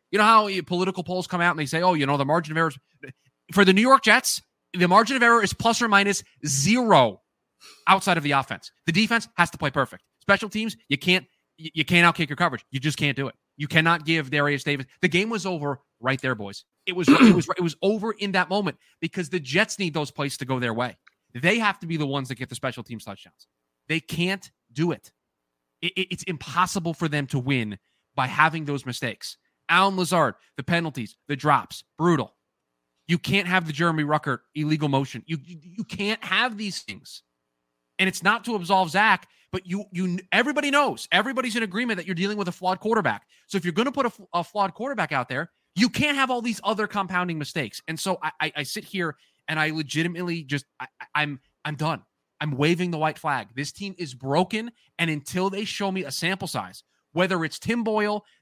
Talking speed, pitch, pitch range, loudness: 220 wpm, 170 Hz, 145-195 Hz, -24 LUFS